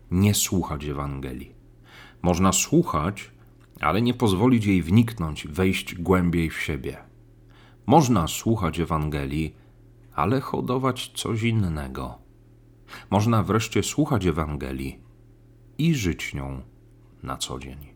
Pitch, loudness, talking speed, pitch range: 100 Hz, -24 LUFS, 105 wpm, 80-120 Hz